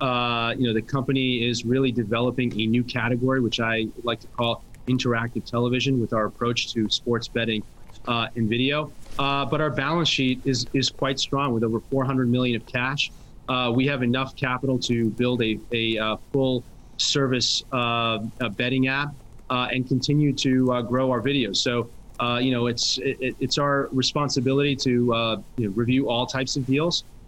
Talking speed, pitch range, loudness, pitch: 185 wpm, 115-135 Hz, -24 LUFS, 125 Hz